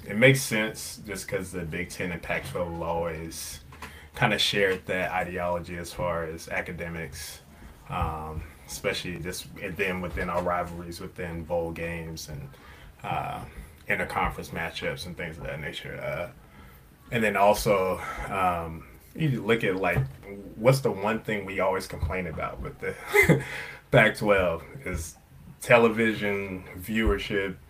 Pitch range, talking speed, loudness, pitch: 80-100 Hz, 140 wpm, -27 LUFS, 85 Hz